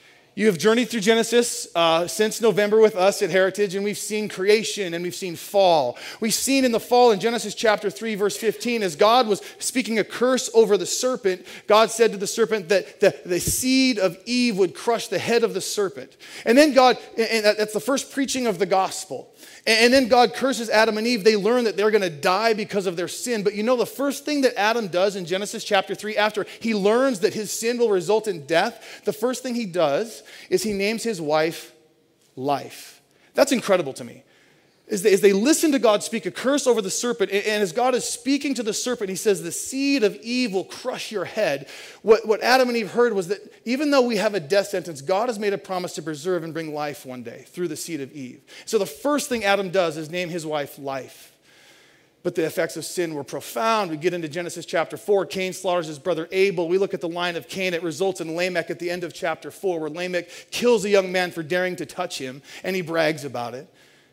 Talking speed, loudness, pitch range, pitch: 235 wpm, -22 LUFS, 175-230 Hz, 205 Hz